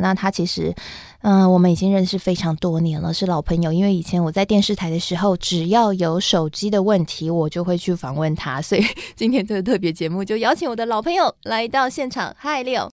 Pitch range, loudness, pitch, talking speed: 165-205 Hz, -20 LUFS, 185 Hz, 340 characters per minute